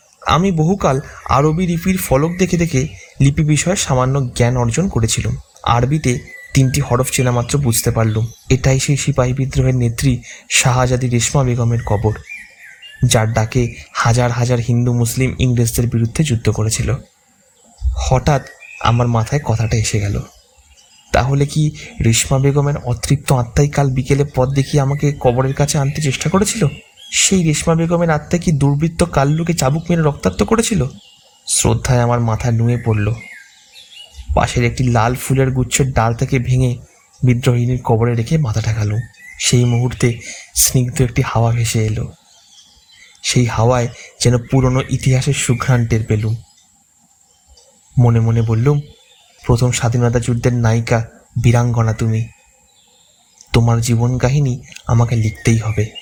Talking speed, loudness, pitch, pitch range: 125 wpm, -16 LUFS, 125 Hz, 120-140 Hz